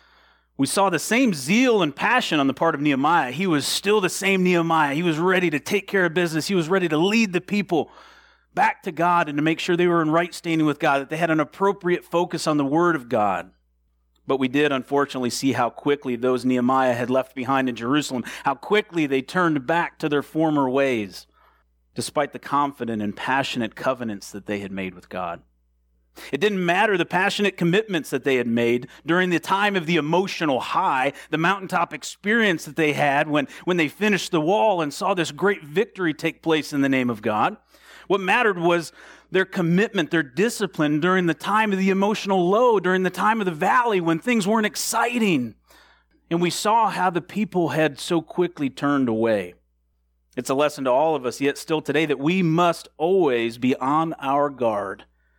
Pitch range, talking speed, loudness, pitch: 135-185 Hz, 205 wpm, -22 LUFS, 160 Hz